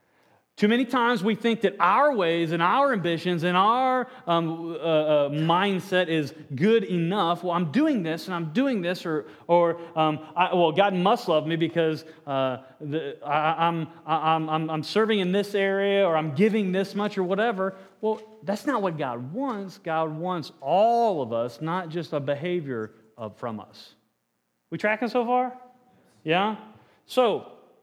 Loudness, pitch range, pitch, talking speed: -25 LUFS, 160-210 Hz, 175 Hz, 170 wpm